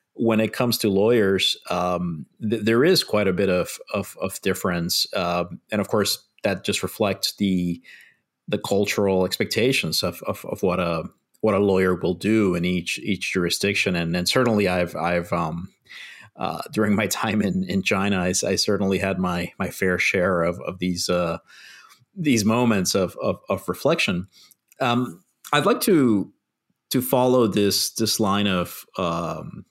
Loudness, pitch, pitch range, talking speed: -22 LUFS, 95 Hz, 90-110 Hz, 170 wpm